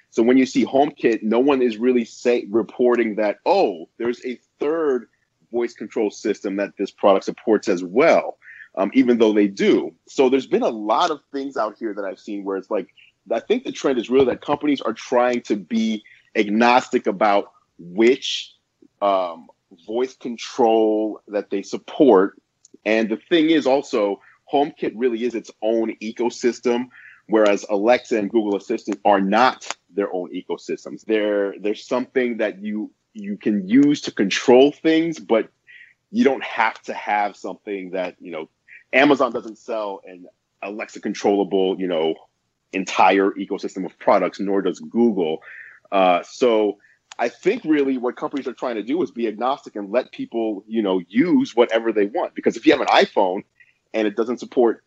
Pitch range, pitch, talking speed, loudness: 105-130 Hz, 115 Hz, 170 wpm, -20 LUFS